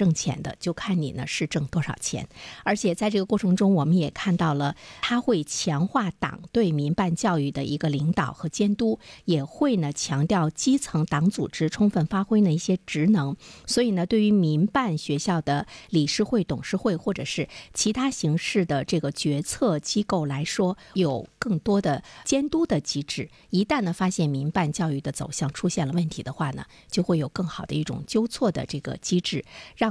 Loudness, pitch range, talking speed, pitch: -25 LUFS, 150-200 Hz, 280 characters per minute, 175 Hz